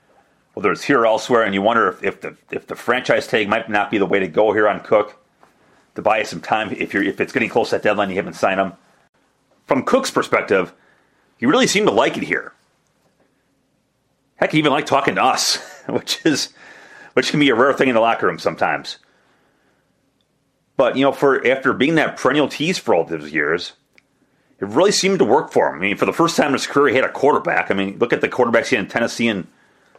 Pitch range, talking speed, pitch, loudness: 95-135 Hz, 235 wpm, 110 Hz, -18 LUFS